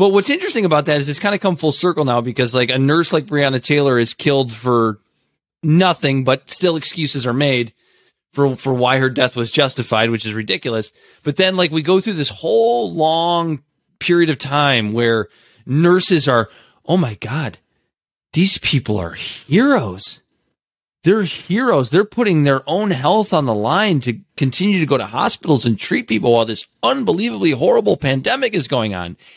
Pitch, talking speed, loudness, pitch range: 145 Hz, 180 wpm, -16 LUFS, 120-175 Hz